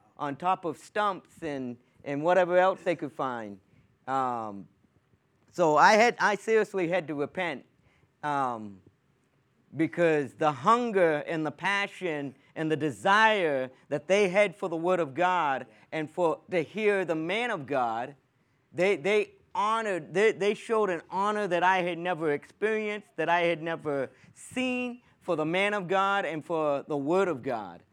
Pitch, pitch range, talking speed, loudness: 170 Hz, 145-195 Hz, 160 wpm, -28 LUFS